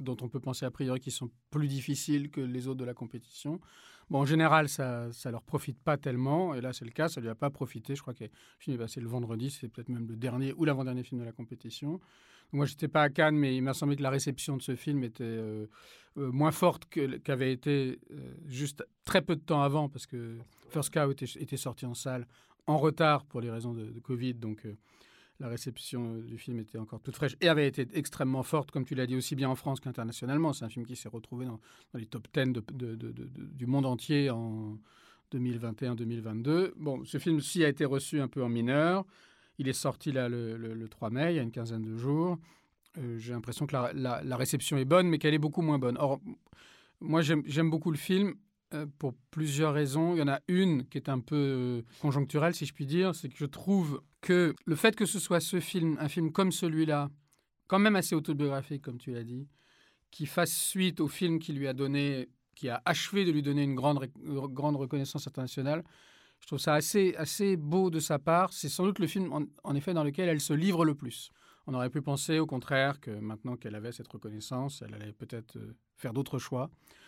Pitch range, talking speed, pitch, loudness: 125-155 Hz, 235 wpm, 140 Hz, -32 LUFS